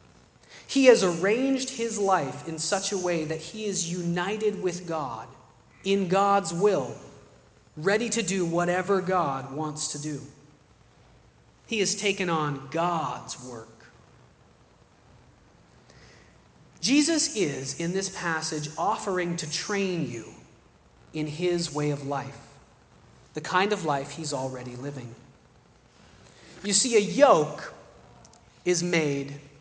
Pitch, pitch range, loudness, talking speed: 170 Hz, 145-195 Hz, -26 LUFS, 120 wpm